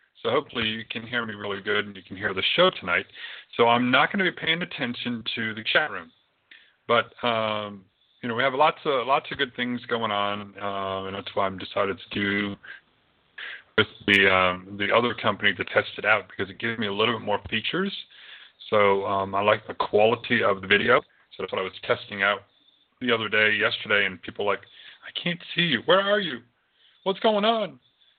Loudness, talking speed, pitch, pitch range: -24 LUFS, 215 wpm, 110 Hz, 100-125 Hz